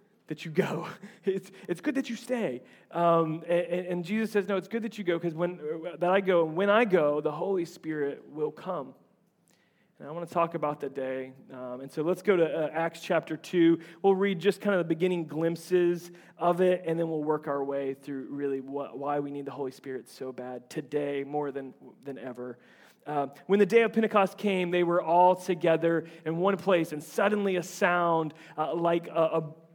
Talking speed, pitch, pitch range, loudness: 210 wpm, 170 Hz, 150-185 Hz, -29 LUFS